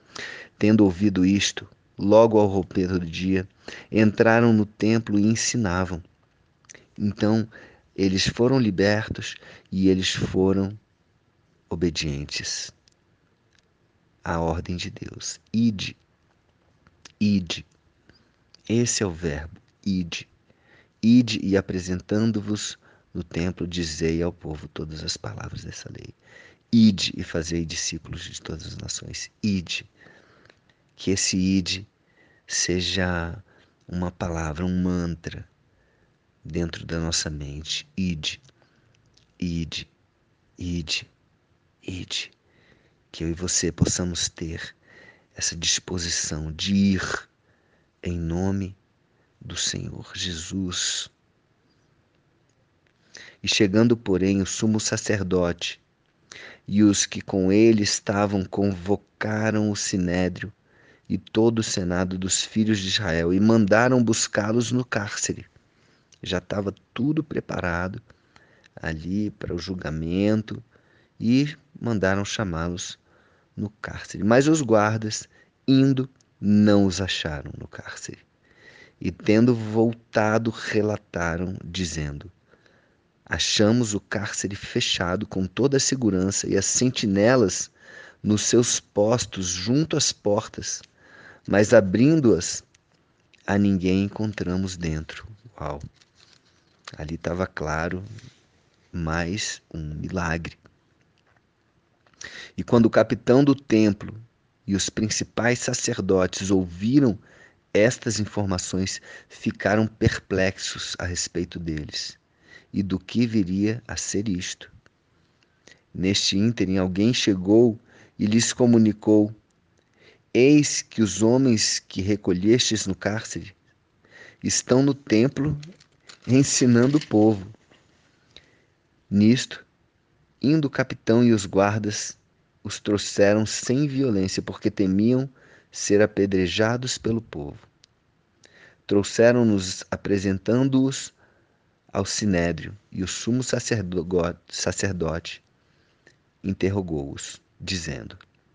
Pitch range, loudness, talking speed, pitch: 90-115 Hz, -23 LUFS, 100 wpm, 100 Hz